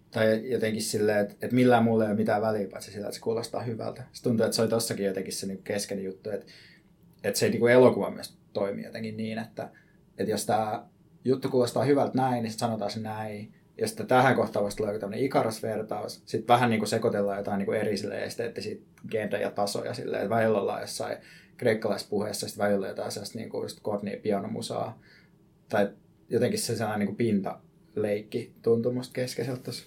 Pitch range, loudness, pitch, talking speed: 105-120 Hz, -28 LUFS, 110 Hz, 175 wpm